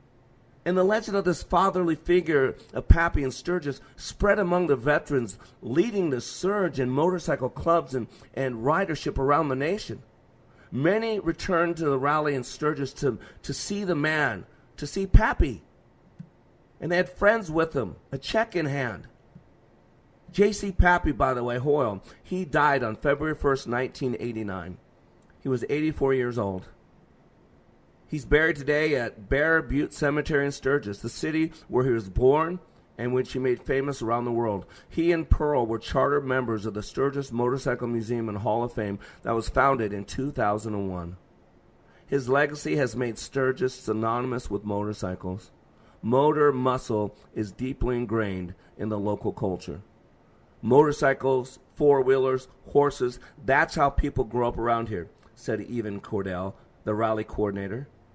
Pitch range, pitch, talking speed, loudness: 115-150 Hz, 130 Hz, 155 wpm, -26 LUFS